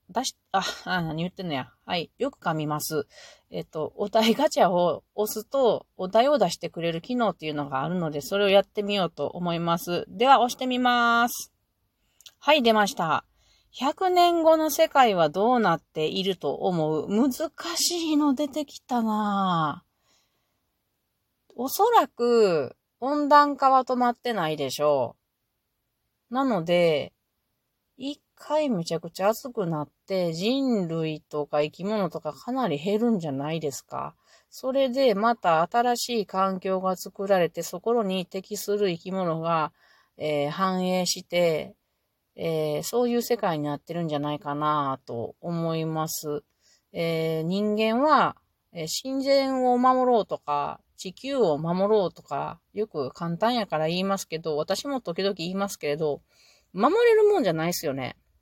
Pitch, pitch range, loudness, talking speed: 190 Hz, 160-240 Hz, -25 LUFS, 280 characters per minute